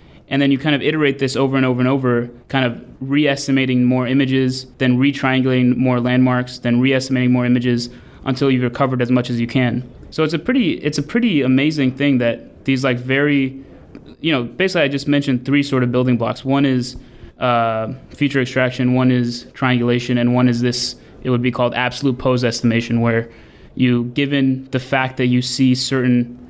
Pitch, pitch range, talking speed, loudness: 130 Hz, 125-135 Hz, 190 wpm, -17 LUFS